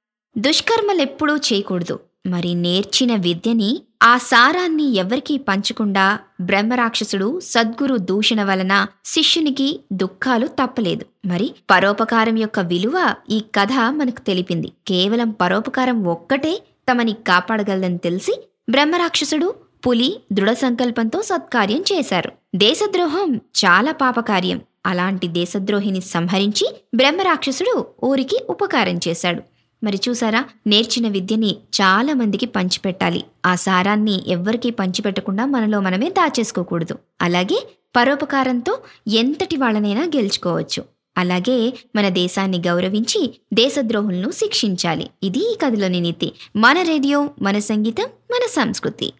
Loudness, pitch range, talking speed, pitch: -18 LUFS, 195-275 Hz, 100 wpm, 225 Hz